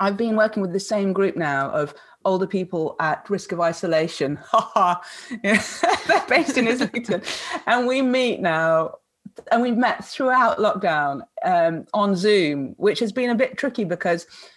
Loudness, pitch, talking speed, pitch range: -21 LUFS, 210 Hz, 160 wpm, 175-250 Hz